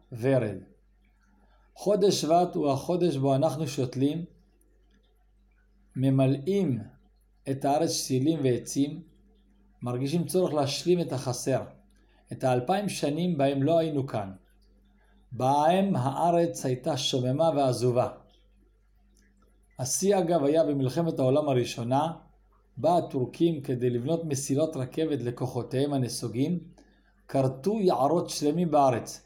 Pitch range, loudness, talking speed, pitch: 125-165 Hz, -27 LUFS, 100 wpm, 140 Hz